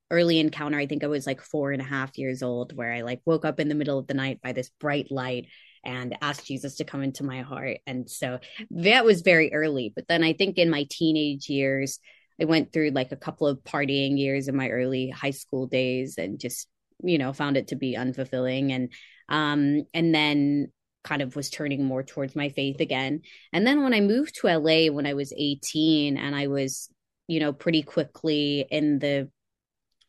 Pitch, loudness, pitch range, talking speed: 140 Hz, -26 LUFS, 135-155 Hz, 215 wpm